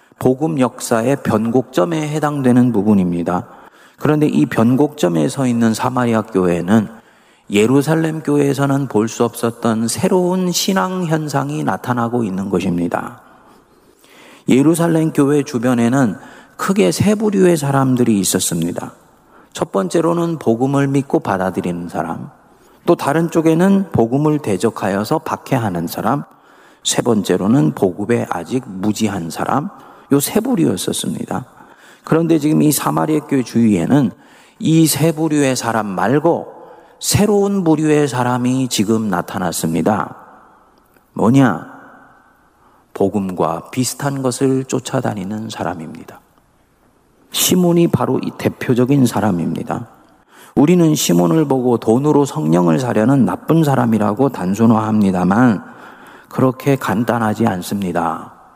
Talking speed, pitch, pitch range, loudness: 280 characters per minute, 130 Hz, 110-150 Hz, -16 LUFS